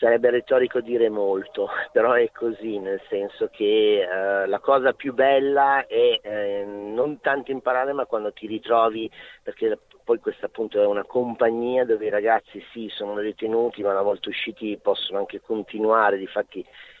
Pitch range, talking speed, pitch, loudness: 105-140 Hz, 160 wpm, 115 Hz, -23 LUFS